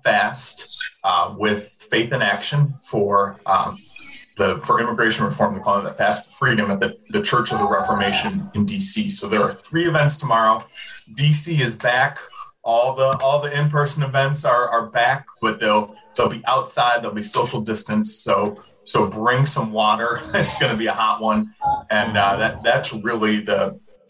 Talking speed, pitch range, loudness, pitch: 185 wpm, 110-185 Hz, -20 LUFS, 135 Hz